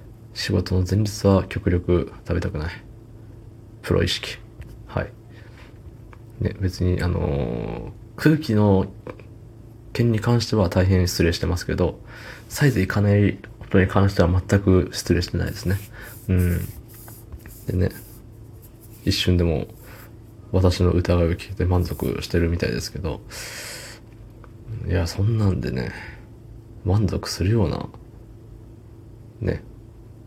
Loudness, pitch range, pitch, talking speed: -22 LUFS, 90-115 Hz, 110 Hz, 225 characters per minute